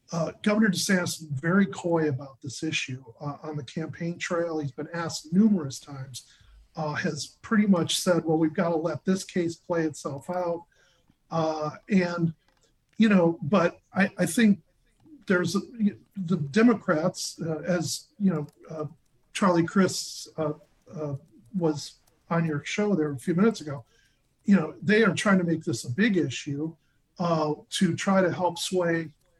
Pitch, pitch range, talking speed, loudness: 165 Hz, 150-185 Hz, 165 wpm, -26 LUFS